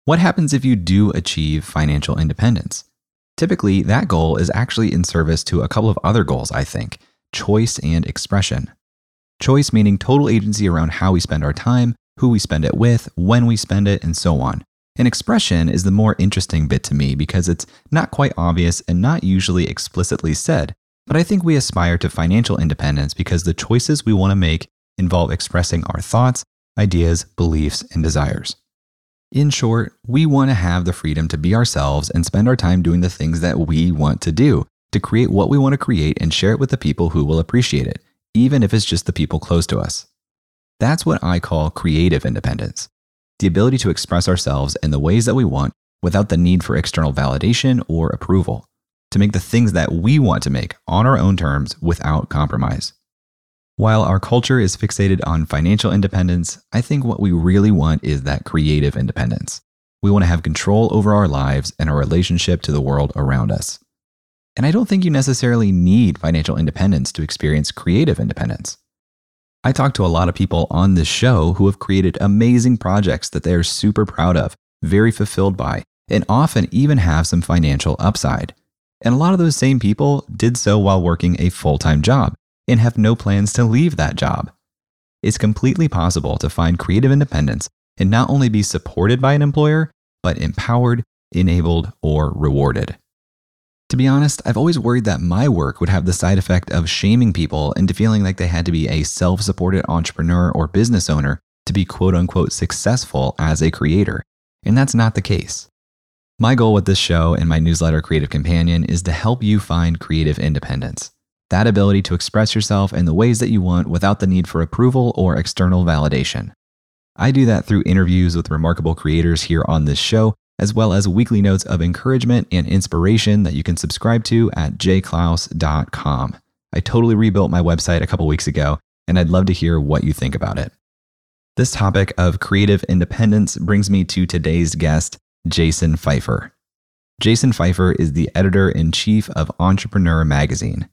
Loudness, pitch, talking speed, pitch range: -17 LUFS, 90 Hz, 190 wpm, 80-110 Hz